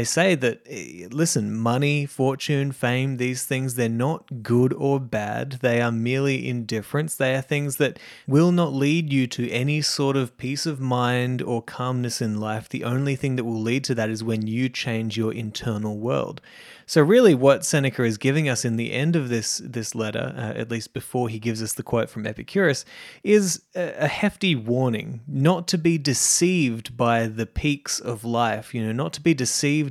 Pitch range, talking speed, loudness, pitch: 115-140 Hz, 195 wpm, -23 LUFS, 125 Hz